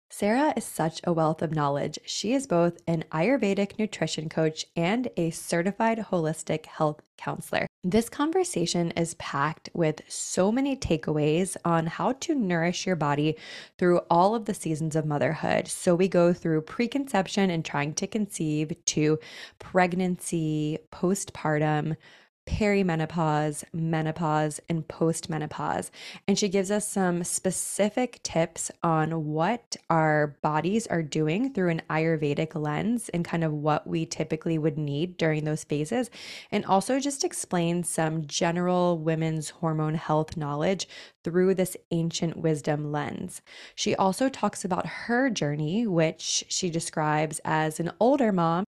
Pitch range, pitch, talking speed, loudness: 155-195 Hz, 170 Hz, 140 wpm, -27 LUFS